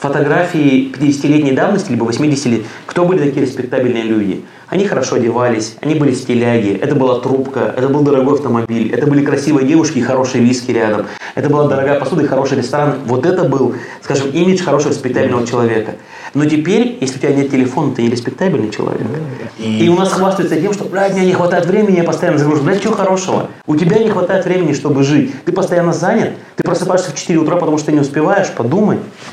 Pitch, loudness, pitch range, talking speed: 145 Hz, -14 LUFS, 125-175 Hz, 200 wpm